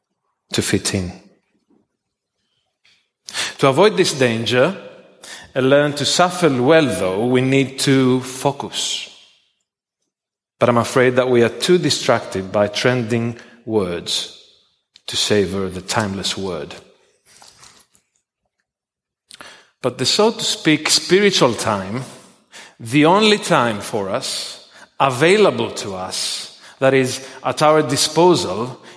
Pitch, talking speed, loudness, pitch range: 130 Hz, 110 wpm, -17 LUFS, 115-155 Hz